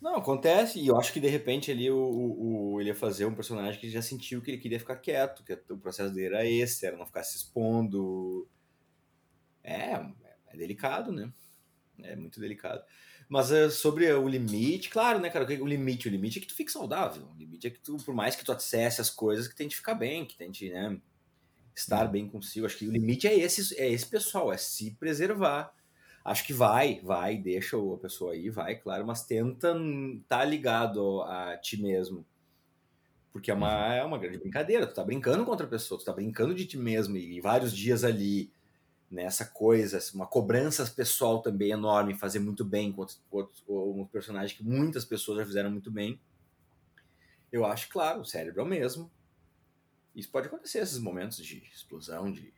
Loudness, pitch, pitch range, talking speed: -31 LUFS, 110 Hz, 100-130 Hz, 205 wpm